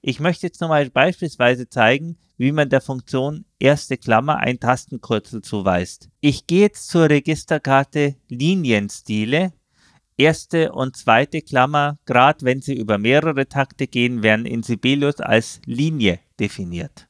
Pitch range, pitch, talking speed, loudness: 120-150 Hz, 135 Hz, 135 wpm, -19 LUFS